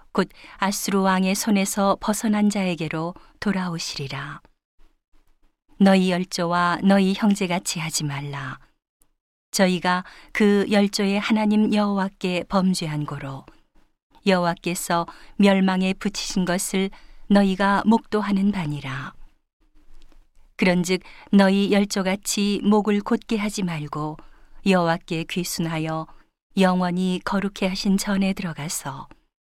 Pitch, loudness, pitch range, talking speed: 190 Hz, -22 LUFS, 175-205 Hz, 240 characters per minute